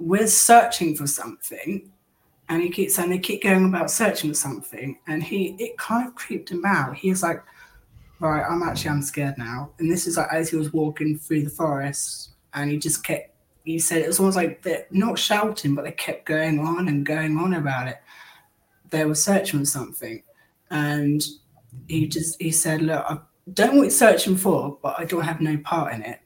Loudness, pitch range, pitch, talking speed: -22 LUFS, 150-185 Hz, 160 Hz, 210 wpm